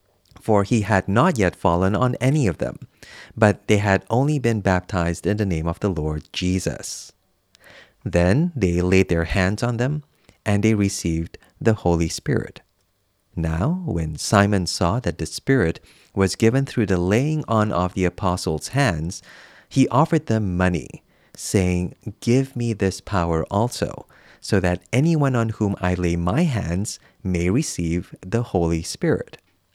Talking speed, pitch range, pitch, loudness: 155 wpm, 90-115 Hz, 100 Hz, -21 LUFS